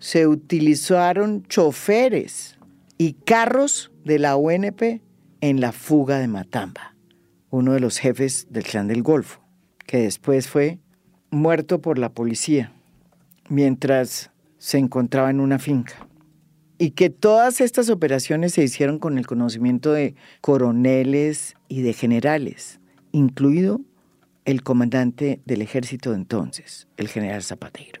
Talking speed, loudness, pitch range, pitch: 125 wpm, -20 LUFS, 125-165 Hz, 140 Hz